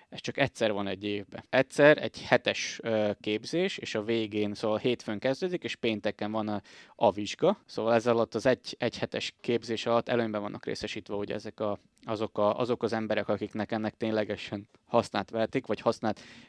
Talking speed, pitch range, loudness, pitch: 185 wpm, 105-115 Hz, -30 LUFS, 110 Hz